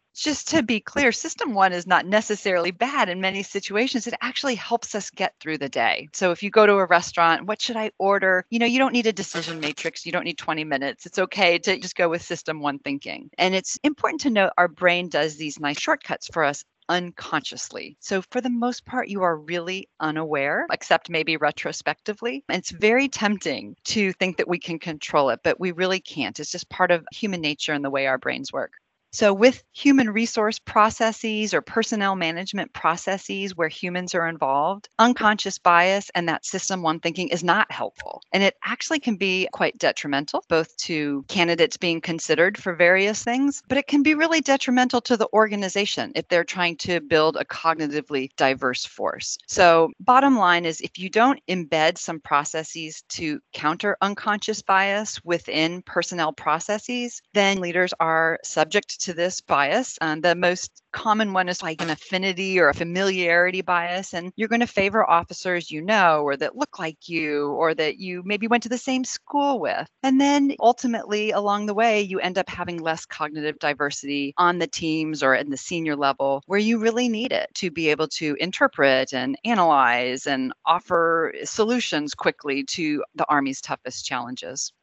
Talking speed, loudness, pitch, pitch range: 190 wpm, -22 LUFS, 180 Hz, 160-215 Hz